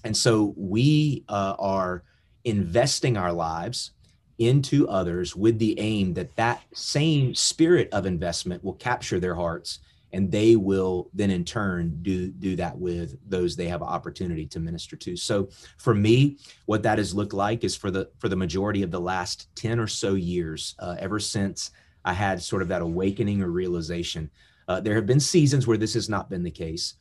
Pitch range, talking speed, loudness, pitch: 90-110 Hz, 185 wpm, -25 LUFS, 95 Hz